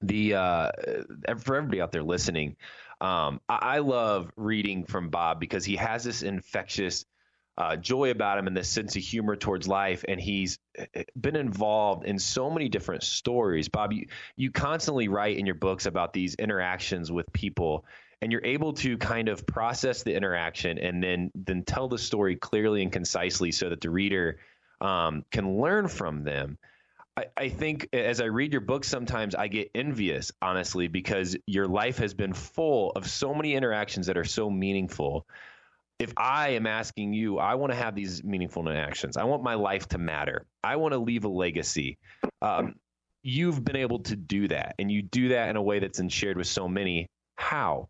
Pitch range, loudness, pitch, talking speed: 95-115 Hz, -29 LUFS, 100 Hz, 185 wpm